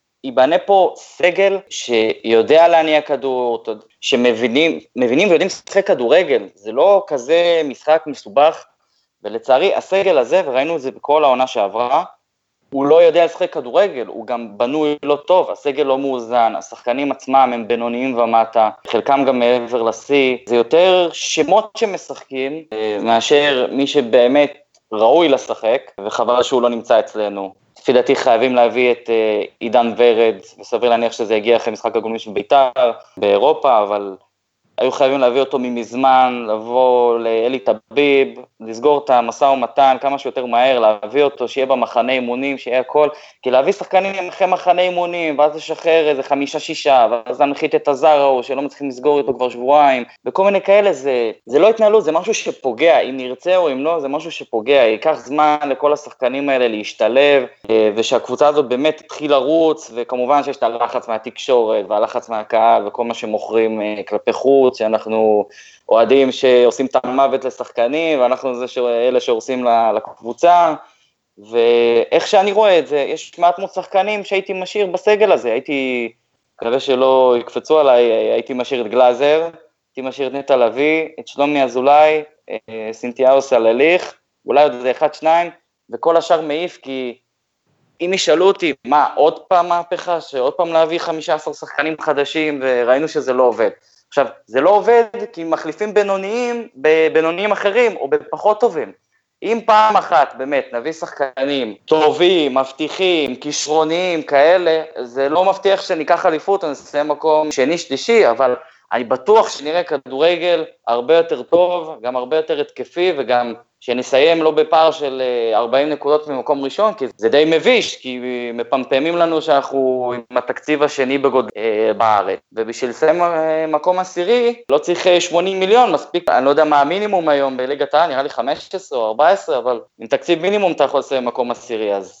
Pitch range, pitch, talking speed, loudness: 125-170 Hz, 145 Hz, 145 wpm, -16 LUFS